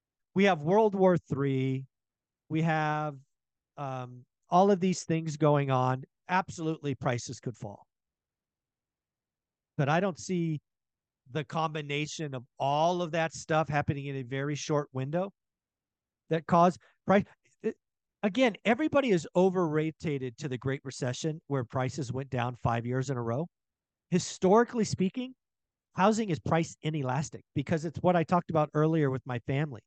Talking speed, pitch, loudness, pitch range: 145 wpm, 155 Hz, -30 LUFS, 135-175 Hz